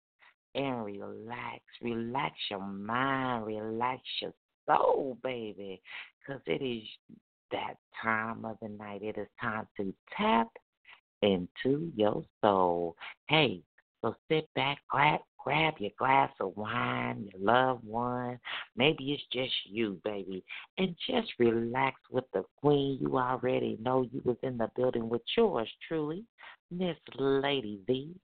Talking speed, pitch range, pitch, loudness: 135 wpm, 105-135 Hz, 120 Hz, -32 LUFS